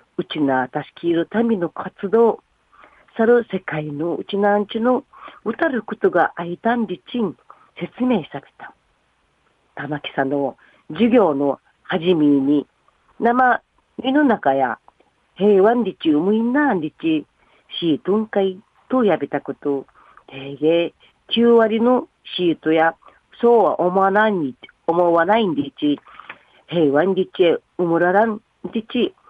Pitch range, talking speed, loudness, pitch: 155-230 Hz, 225 characters per minute, -19 LUFS, 190 Hz